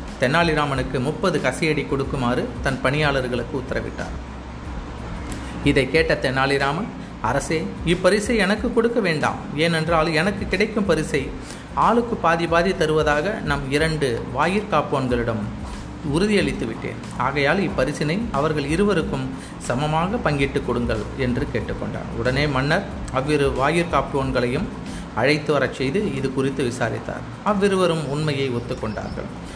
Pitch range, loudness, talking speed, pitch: 125-165 Hz, -22 LUFS, 105 wpm, 145 Hz